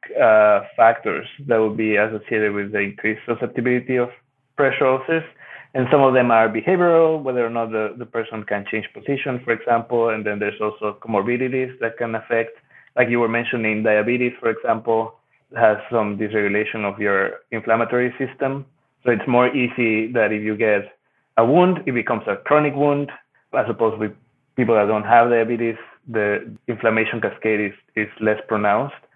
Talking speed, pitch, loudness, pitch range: 170 wpm, 115 Hz, -20 LUFS, 110-125 Hz